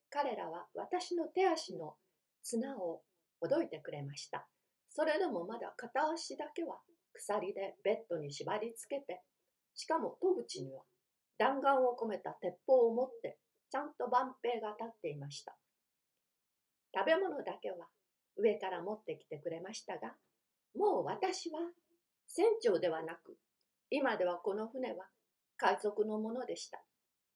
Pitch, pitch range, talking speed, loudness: 255 Hz, 210-325 Hz, 260 characters per minute, -38 LUFS